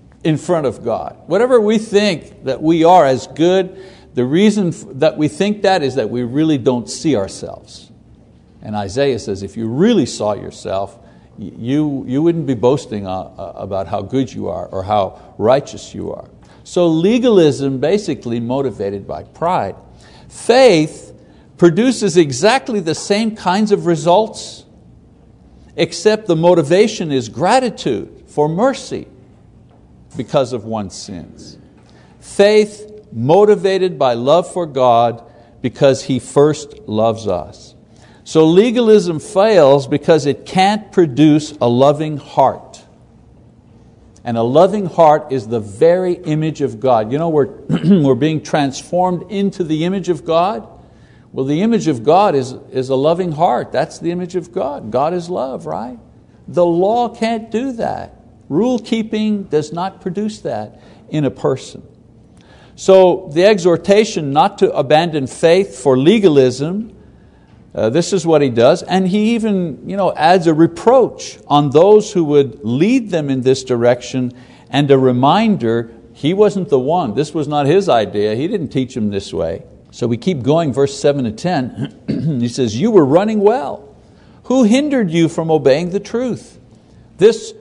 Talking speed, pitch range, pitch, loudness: 150 wpm, 130-190 Hz, 155 Hz, -15 LUFS